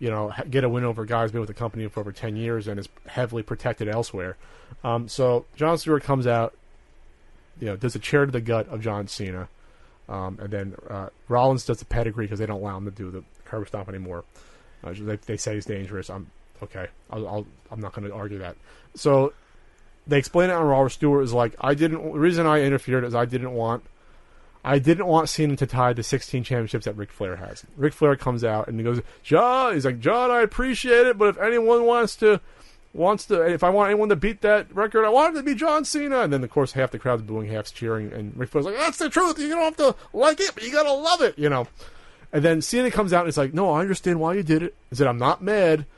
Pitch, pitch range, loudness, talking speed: 130 Hz, 110-170 Hz, -23 LUFS, 250 wpm